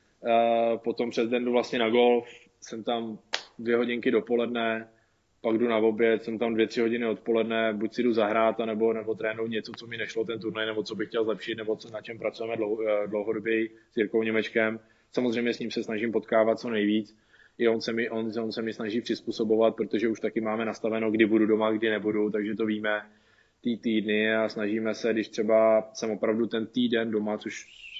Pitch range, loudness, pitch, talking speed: 110-115 Hz, -27 LUFS, 110 Hz, 205 wpm